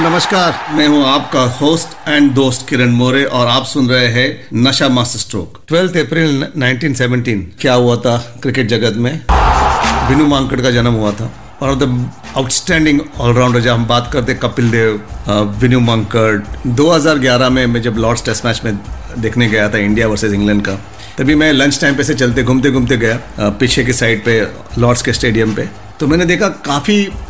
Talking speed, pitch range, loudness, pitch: 135 wpm, 115-140 Hz, -12 LUFS, 125 Hz